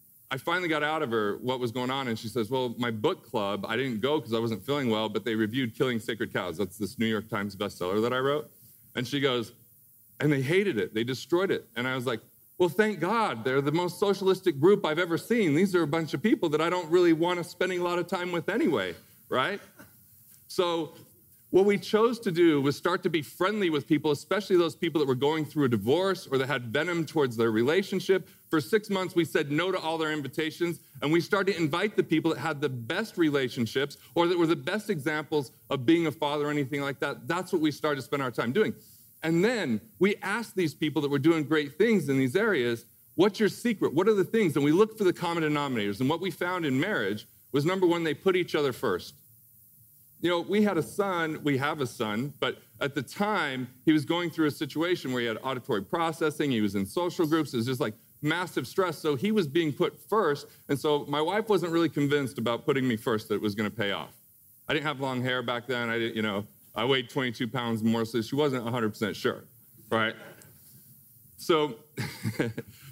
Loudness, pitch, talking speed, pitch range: -28 LUFS, 150 Hz, 235 wpm, 125-175 Hz